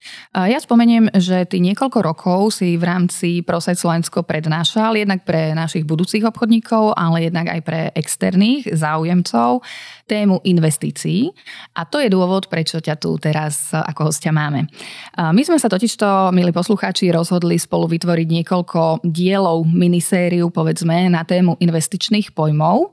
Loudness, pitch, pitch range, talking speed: -17 LUFS, 175 Hz, 165-195 Hz, 140 wpm